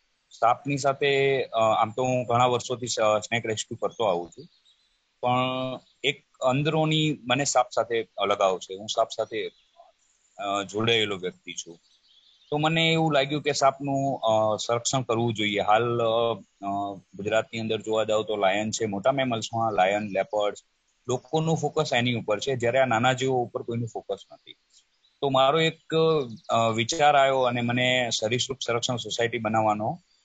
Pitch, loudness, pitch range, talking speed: 120 Hz, -25 LUFS, 110-135 Hz, 145 wpm